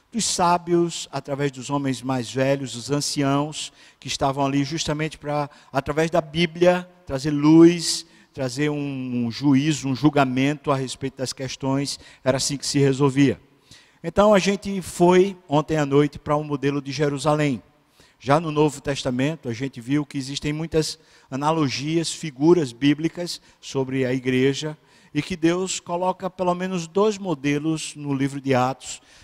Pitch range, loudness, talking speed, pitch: 135-165 Hz, -22 LUFS, 155 wpm, 145 Hz